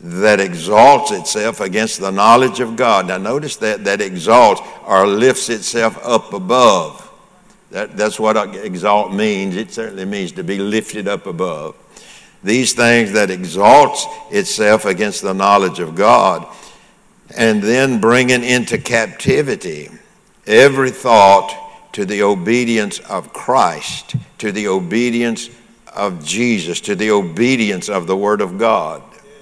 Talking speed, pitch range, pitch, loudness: 135 wpm, 105-130 Hz, 115 Hz, -14 LUFS